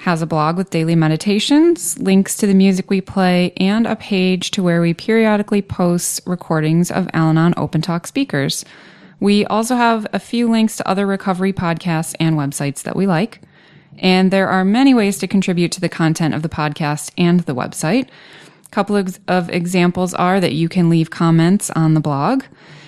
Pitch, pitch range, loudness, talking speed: 180 Hz, 165-200 Hz, -16 LUFS, 185 wpm